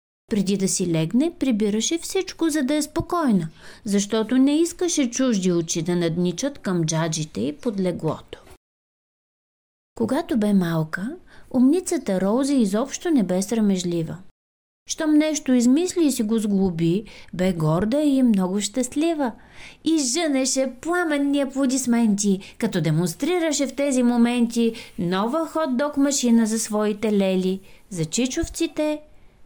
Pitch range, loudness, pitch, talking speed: 195-295 Hz, -22 LUFS, 240 Hz, 120 wpm